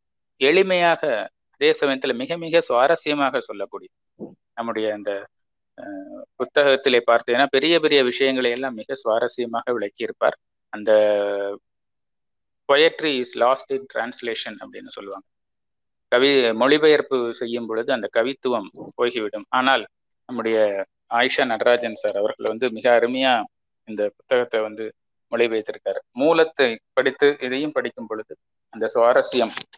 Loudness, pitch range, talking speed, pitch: -21 LUFS, 115-160 Hz, 105 wpm, 130 Hz